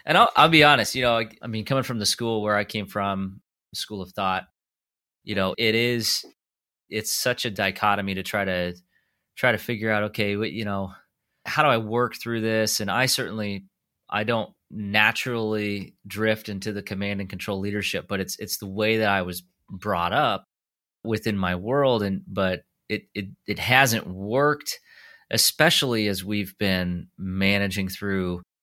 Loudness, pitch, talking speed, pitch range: -24 LUFS, 105 Hz, 175 wpm, 95-115 Hz